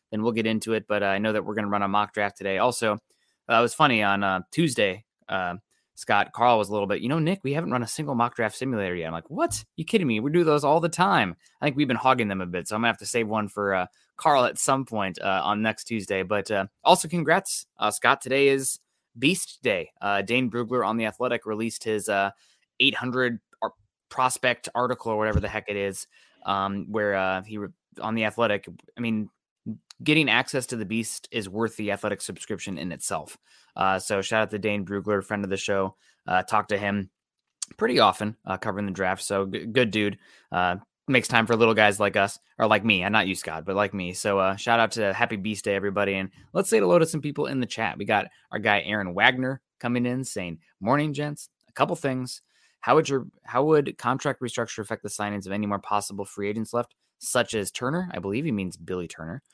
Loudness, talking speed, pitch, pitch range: -25 LUFS, 240 wpm, 110 Hz, 100-125 Hz